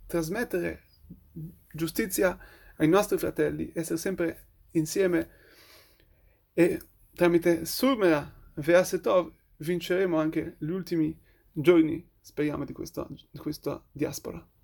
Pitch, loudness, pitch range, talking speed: 165 Hz, -28 LUFS, 150-175 Hz, 95 wpm